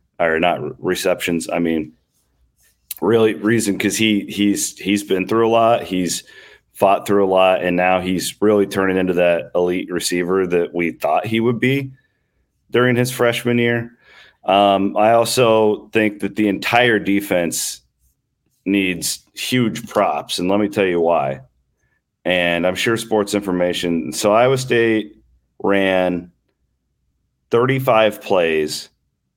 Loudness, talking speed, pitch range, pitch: -17 LUFS, 140 wpm, 85-110 Hz, 100 Hz